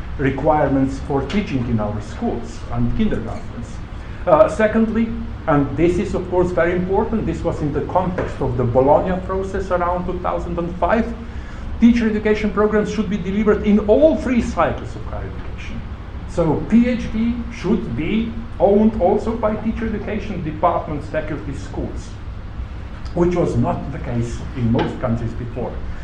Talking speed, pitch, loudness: 145 wpm, 170 Hz, -19 LUFS